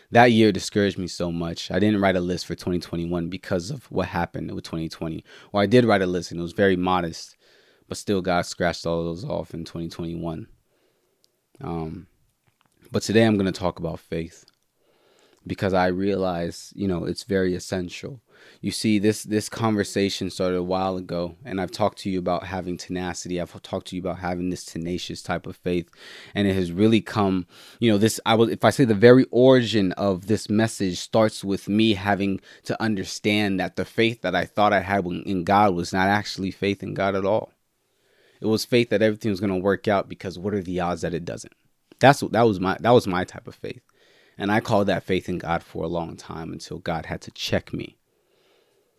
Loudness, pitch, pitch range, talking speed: -23 LUFS, 95 Hz, 90-110 Hz, 215 wpm